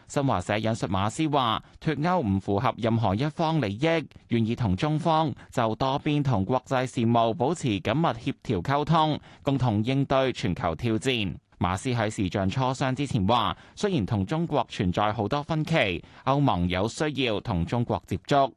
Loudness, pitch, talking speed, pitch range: -26 LUFS, 130 Hz, 255 characters per minute, 105-145 Hz